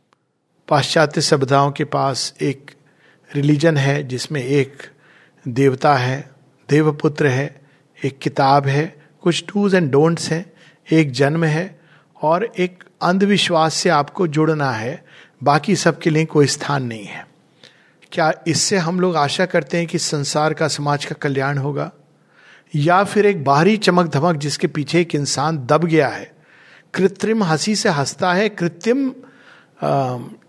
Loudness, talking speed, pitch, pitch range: -18 LUFS, 140 wpm, 155 Hz, 140-175 Hz